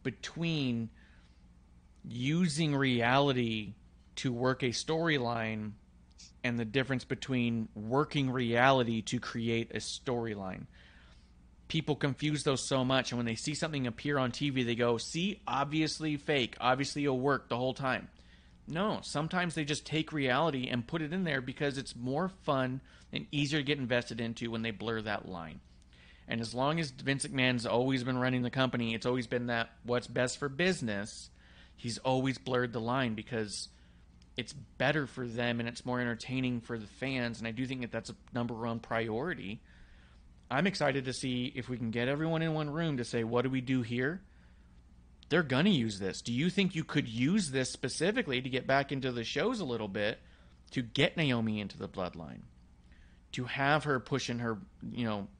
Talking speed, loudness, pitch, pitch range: 180 wpm, -33 LUFS, 125 Hz, 110-135 Hz